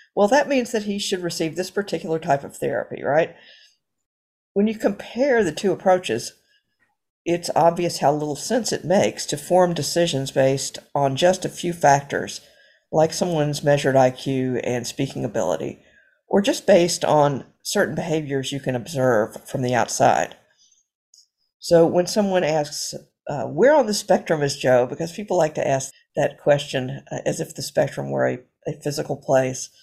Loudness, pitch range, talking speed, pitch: -21 LUFS, 140-185 Hz, 165 wpm, 155 Hz